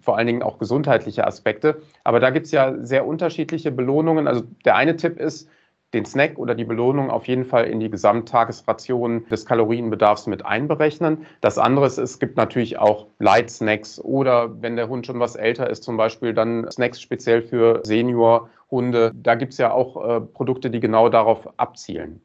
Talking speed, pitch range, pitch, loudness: 185 wpm, 115-135 Hz, 120 Hz, -20 LUFS